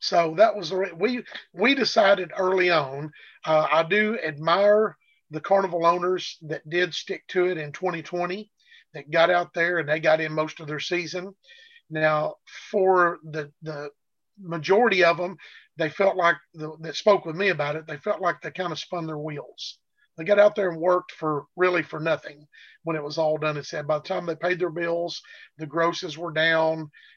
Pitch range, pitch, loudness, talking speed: 155-185 Hz, 170 Hz, -24 LUFS, 195 wpm